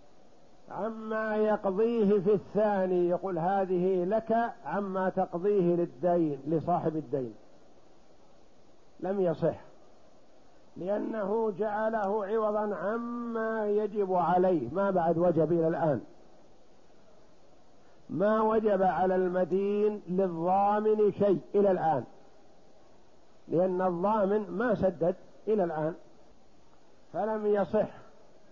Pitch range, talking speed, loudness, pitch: 175-210 Hz, 85 wpm, -29 LUFS, 195 Hz